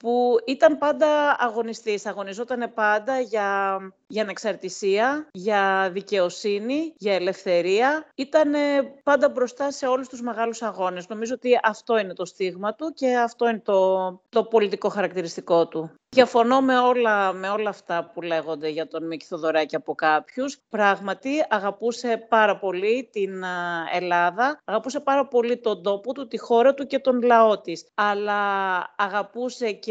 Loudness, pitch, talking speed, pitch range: -23 LUFS, 215 Hz, 145 wpm, 190-250 Hz